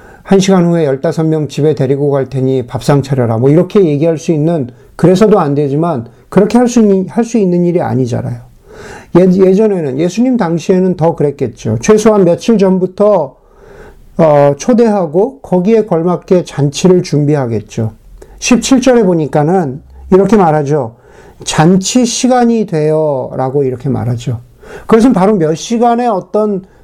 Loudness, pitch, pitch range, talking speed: -11 LUFS, 170 Hz, 140-205 Hz, 300 characters per minute